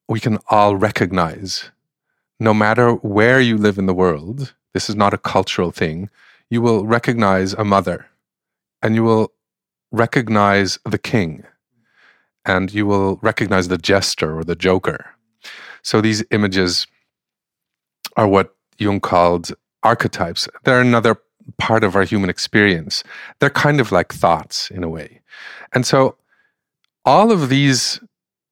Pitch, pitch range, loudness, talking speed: 105 Hz, 95-115 Hz, -17 LUFS, 140 wpm